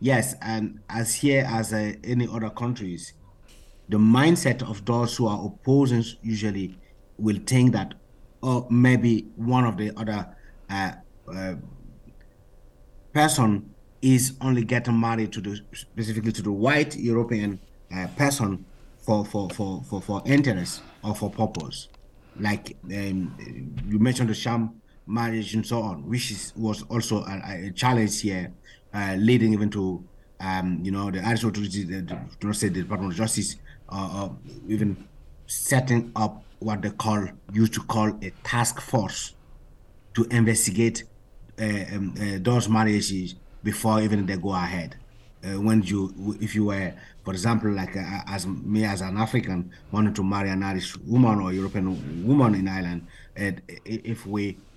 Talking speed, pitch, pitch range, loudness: 150 wpm, 105 Hz, 95-115 Hz, -25 LUFS